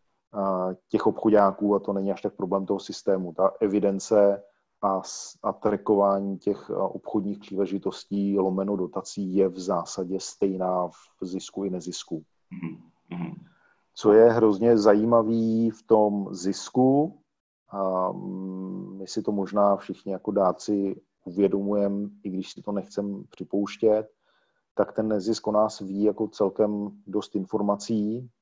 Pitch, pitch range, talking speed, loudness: 100 Hz, 95-105 Hz, 125 wpm, -25 LUFS